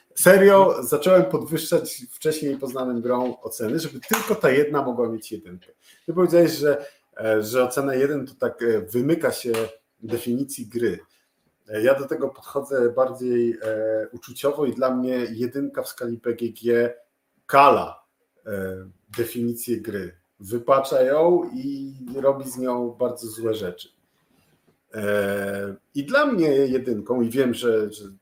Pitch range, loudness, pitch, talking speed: 115-140 Hz, -22 LUFS, 125 Hz, 125 wpm